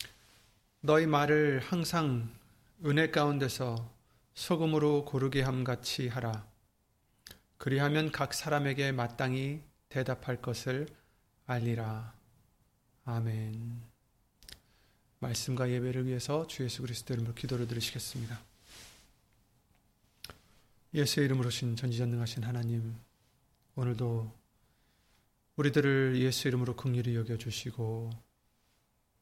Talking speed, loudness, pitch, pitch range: 235 characters per minute, -33 LUFS, 125 Hz, 115-135 Hz